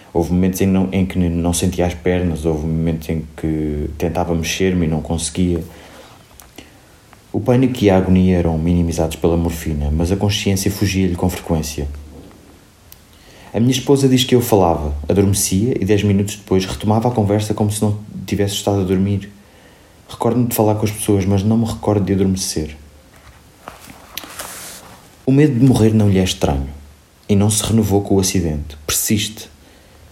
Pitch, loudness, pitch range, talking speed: 95 Hz, -17 LUFS, 85-105 Hz, 165 wpm